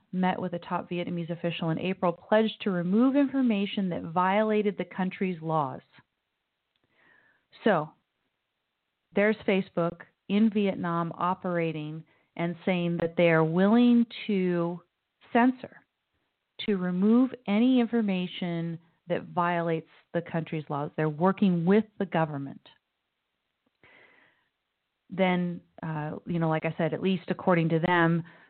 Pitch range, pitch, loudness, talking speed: 170-205 Hz, 180 Hz, -27 LUFS, 120 wpm